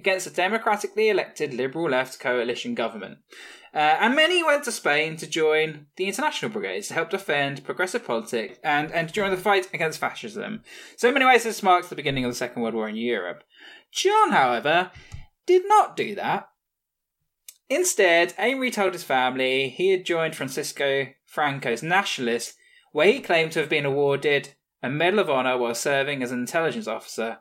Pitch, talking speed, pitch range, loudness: 165 Hz, 175 wpm, 140-215 Hz, -23 LUFS